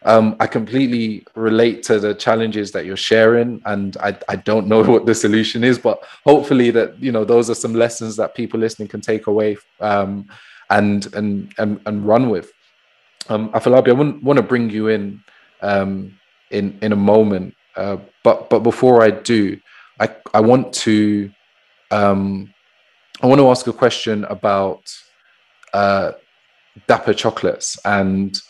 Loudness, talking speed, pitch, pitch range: -16 LUFS, 160 wpm, 110 Hz, 100-115 Hz